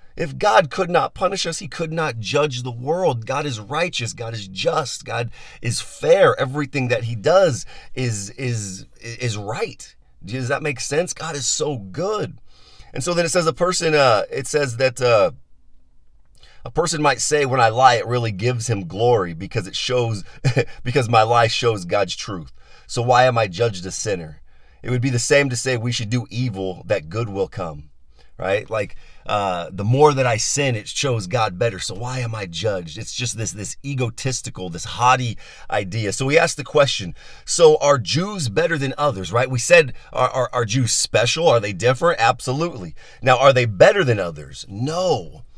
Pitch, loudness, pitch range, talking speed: 125 Hz, -20 LUFS, 110-140 Hz, 195 wpm